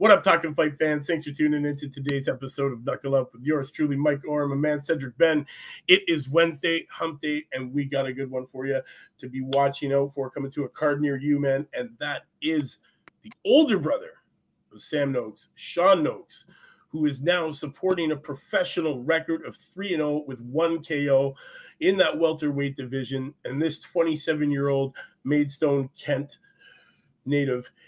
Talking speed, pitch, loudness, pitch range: 185 wpm, 145 Hz, -25 LUFS, 135-160 Hz